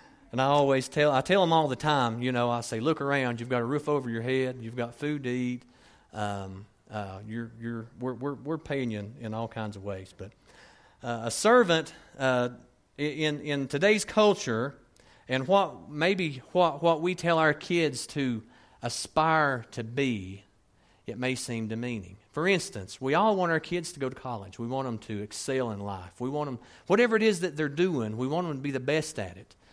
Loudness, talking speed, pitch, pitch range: -28 LUFS, 210 wpm, 130 Hz, 115-155 Hz